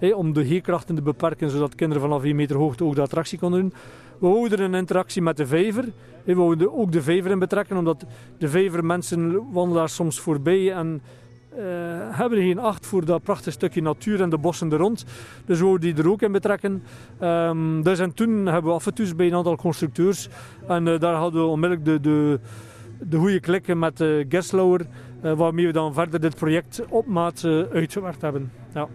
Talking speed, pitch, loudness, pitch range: 210 wpm, 170 Hz, -22 LUFS, 155-185 Hz